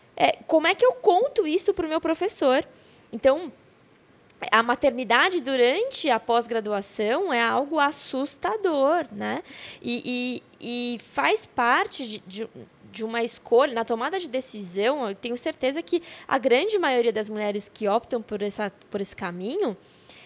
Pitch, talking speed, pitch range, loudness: 250 Hz, 145 wpm, 225-325 Hz, -24 LUFS